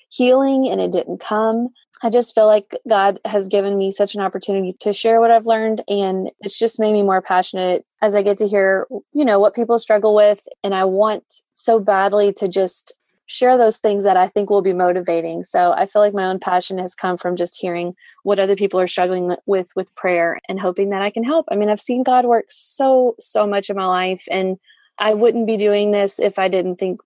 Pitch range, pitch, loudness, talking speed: 190-220 Hz, 200 Hz, -17 LUFS, 230 wpm